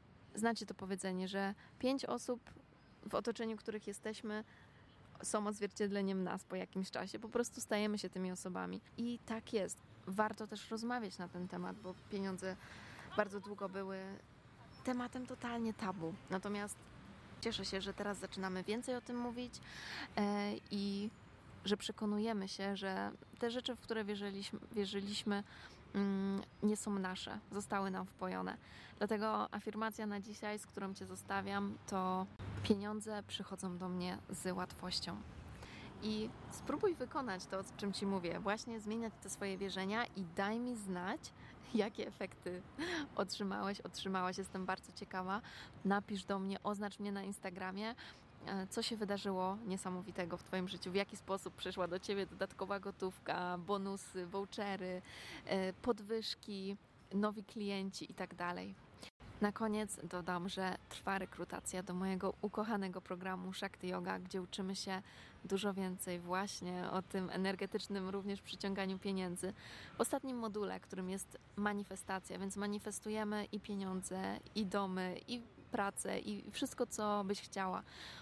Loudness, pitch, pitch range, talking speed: -42 LUFS, 200 Hz, 190-215 Hz, 135 wpm